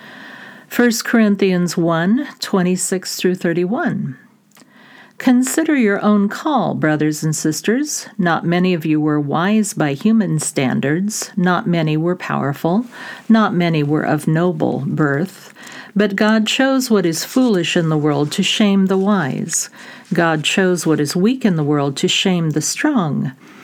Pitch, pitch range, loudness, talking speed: 195 Hz, 165-230 Hz, -17 LUFS, 145 wpm